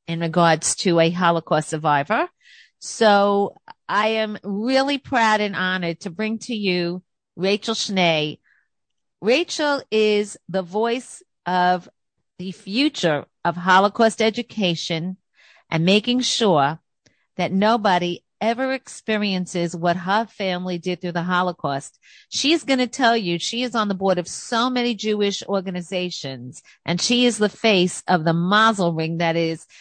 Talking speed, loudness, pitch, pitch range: 140 wpm, -21 LUFS, 190 Hz, 175-225 Hz